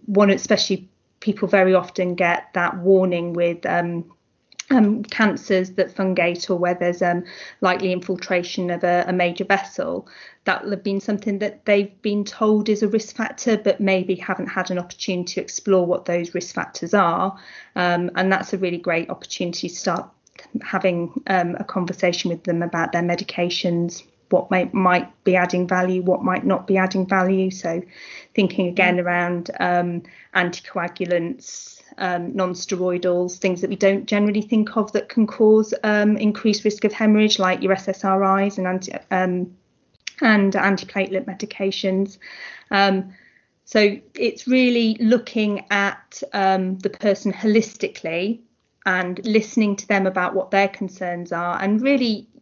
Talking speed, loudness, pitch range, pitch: 155 wpm, -21 LUFS, 180-210 Hz, 190 Hz